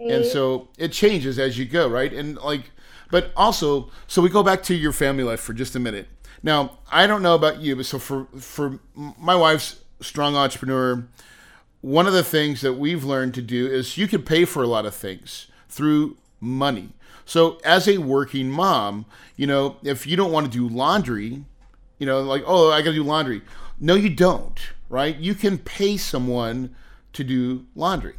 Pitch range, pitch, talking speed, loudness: 130-165 Hz, 140 Hz, 195 wpm, -21 LUFS